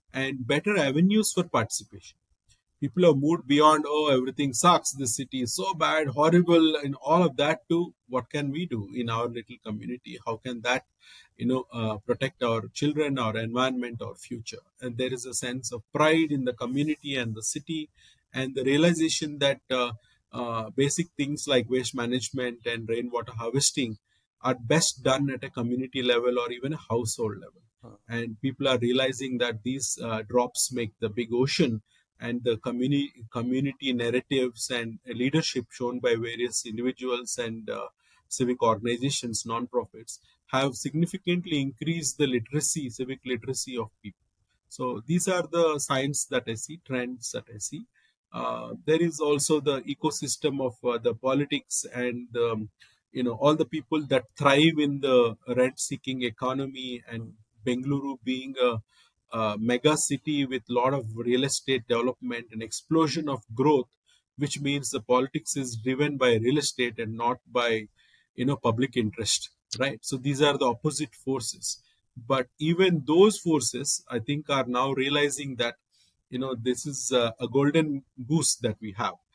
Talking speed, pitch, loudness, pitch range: 165 wpm, 130 Hz, -27 LUFS, 120-145 Hz